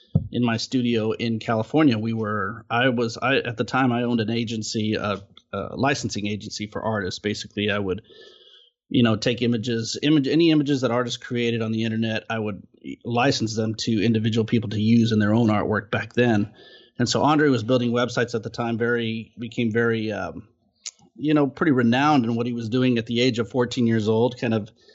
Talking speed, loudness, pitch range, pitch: 205 wpm, -23 LUFS, 110-125 Hz, 115 Hz